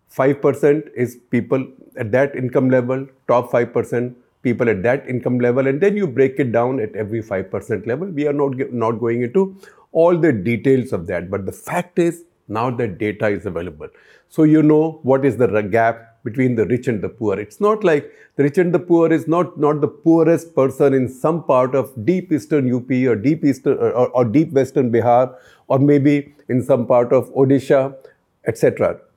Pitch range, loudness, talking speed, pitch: 120-150 Hz, -18 LUFS, 200 wpm, 135 Hz